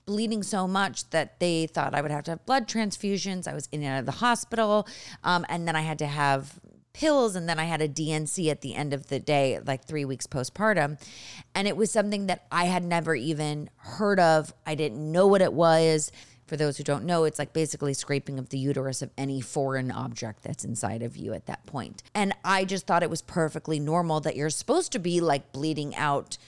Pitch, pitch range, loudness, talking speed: 155 Hz, 140-180 Hz, -27 LUFS, 230 wpm